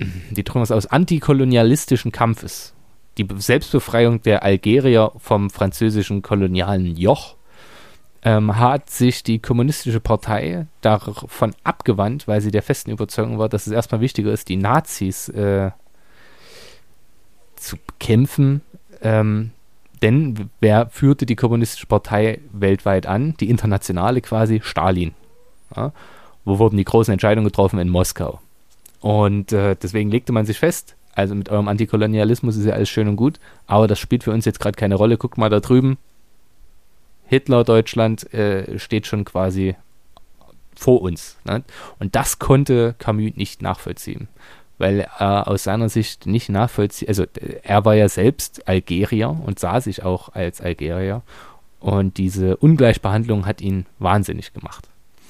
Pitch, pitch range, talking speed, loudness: 110 Hz, 100-120 Hz, 140 wpm, -18 LUFS